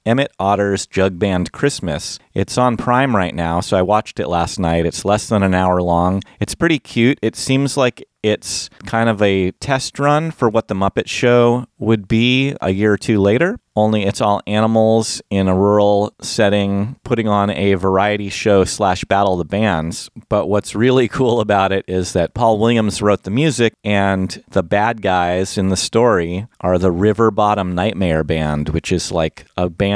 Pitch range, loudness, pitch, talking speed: 95-115 Hz, -16 LUFS, 100 Hz, 190 wpm